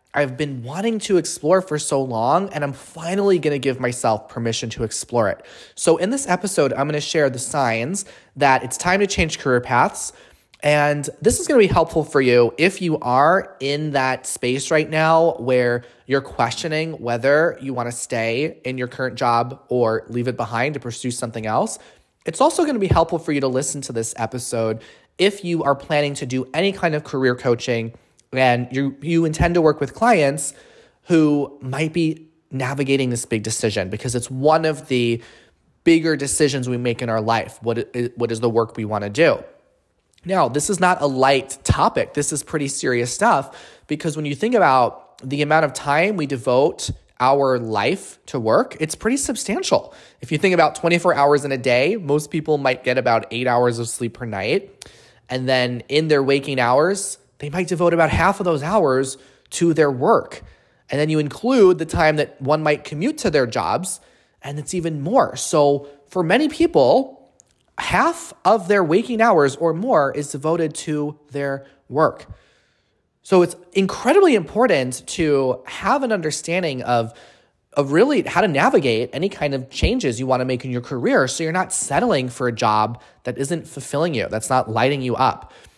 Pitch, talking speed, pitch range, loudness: 140 Hz, 190 wpm, 125-165 Hz, -19 LUFS